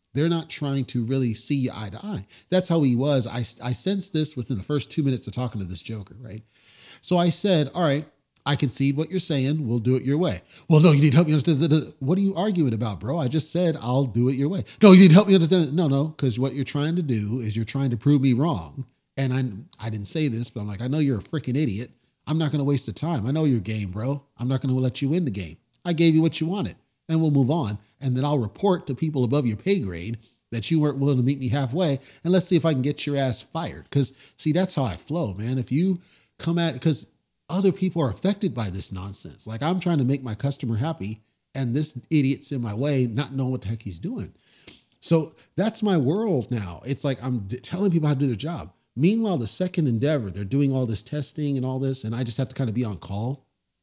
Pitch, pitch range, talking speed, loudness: 140 Hz, 120-160 Hz, 270 wpm, -23 LUFS